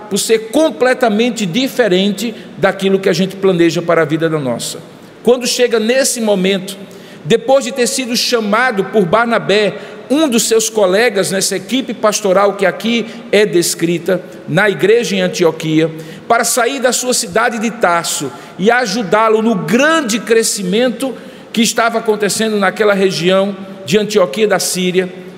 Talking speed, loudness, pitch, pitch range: 145 wpm, -13 LUFS, 210 Hz, 190-235 Hz